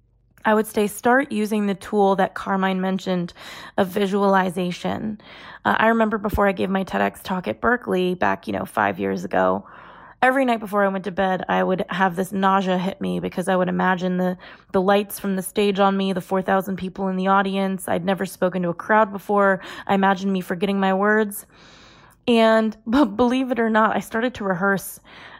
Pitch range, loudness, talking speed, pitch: 185-210 Hz, -21 LUFS, 200 wpm, 195 Hz